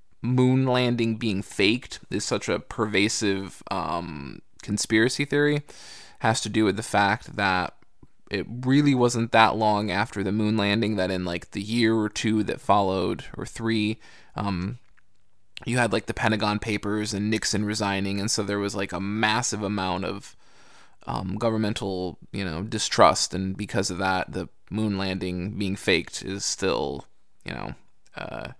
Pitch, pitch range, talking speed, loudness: 105 Hz, 95-110 Hz, 160 wpm, -25 LUFS